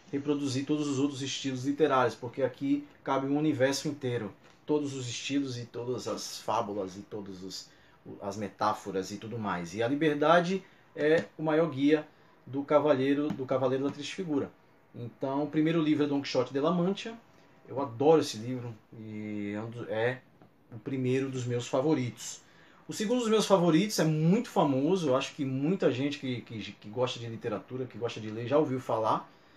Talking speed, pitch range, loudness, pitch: 175 wpm, 120-155 Hz, -30 LUFS, 140 Hz